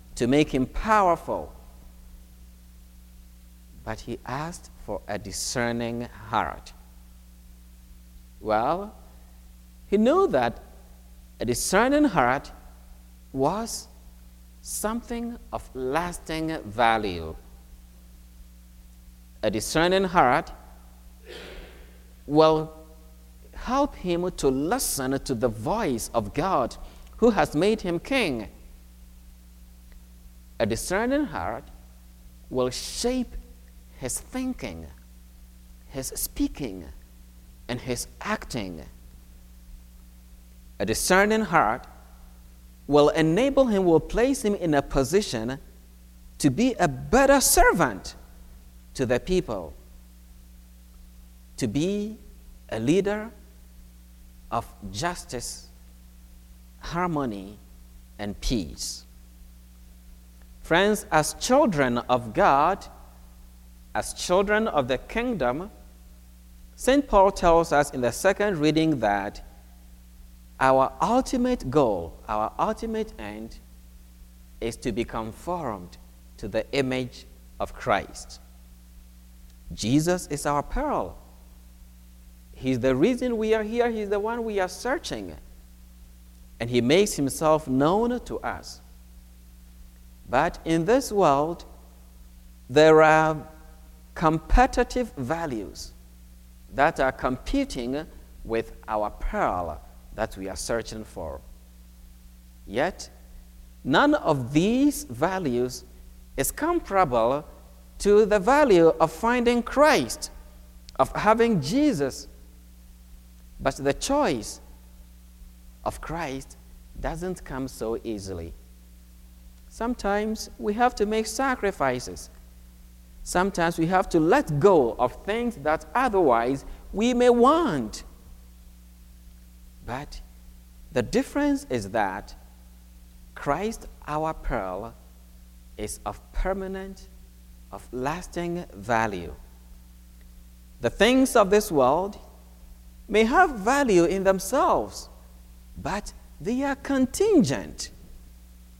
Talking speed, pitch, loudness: 95 wpm, 80 Hz, -25 LUFS